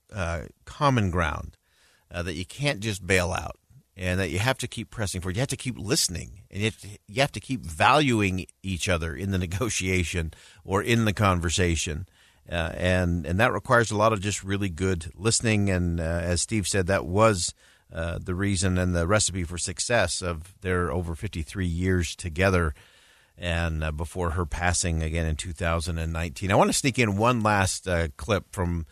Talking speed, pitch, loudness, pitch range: 200 wpm, 95 Hz, -26 LUFS, 85-105 Hz